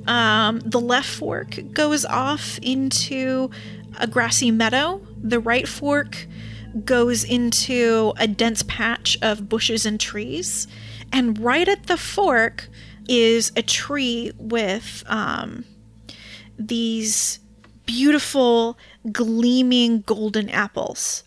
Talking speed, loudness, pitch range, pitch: 105 wpm, -20 LUFS, 215-250 Hz, 230 Hz